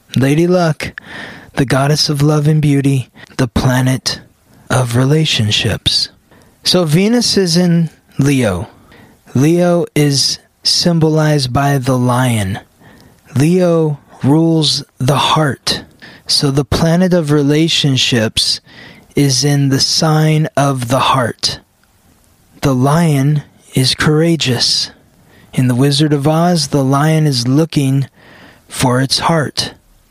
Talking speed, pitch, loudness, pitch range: 110 wpm, 145 Hz, -13 LUFS, 130-155 Hz